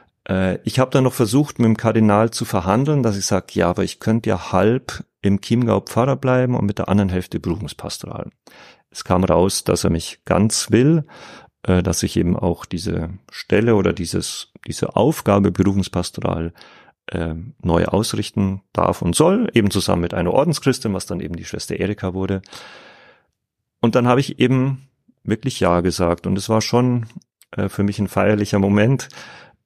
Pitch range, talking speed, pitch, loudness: 95-120 Hz, 165 wpm, 105 Hz, -19 LUFS